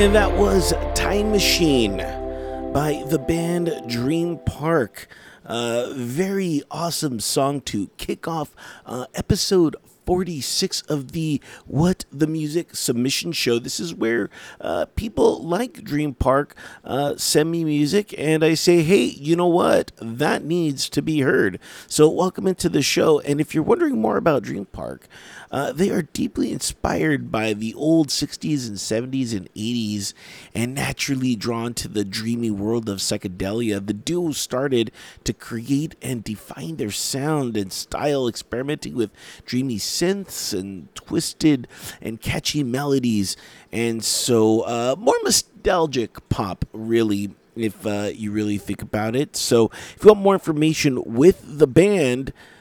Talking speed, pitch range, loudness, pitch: 150 wpm, 110-160 Hz, -21 LUFS, 135 Hz